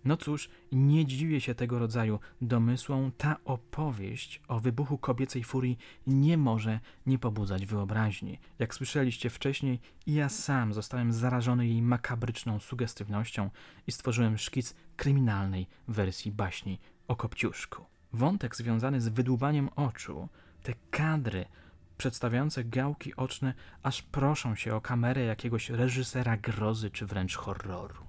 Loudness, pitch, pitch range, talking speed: -32 LUFS, 125 Hz, 110-135 Hz, 125 wpm